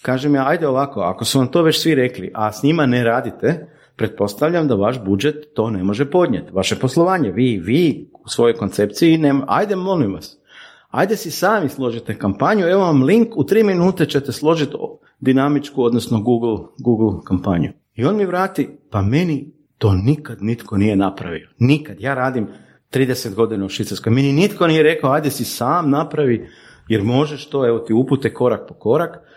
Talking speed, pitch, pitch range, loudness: 180 wpm, 130 Hz, 110-155 Hz, -18 LUFS